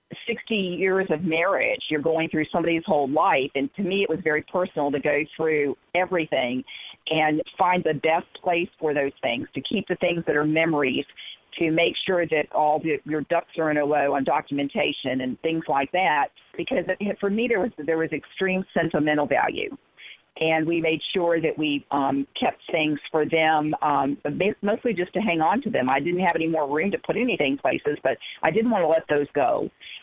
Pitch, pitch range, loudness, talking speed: 160 Hz, 150-180 Hz, -24 LUFS, 200 wpm